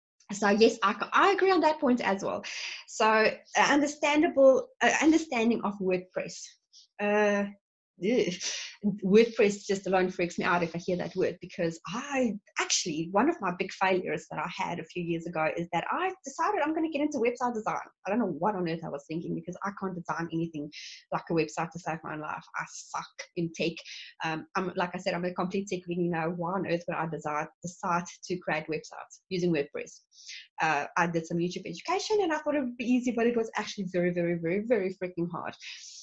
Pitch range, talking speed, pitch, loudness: 170-230 Hz, 215 wpm, 190 Hz, -29 LUFS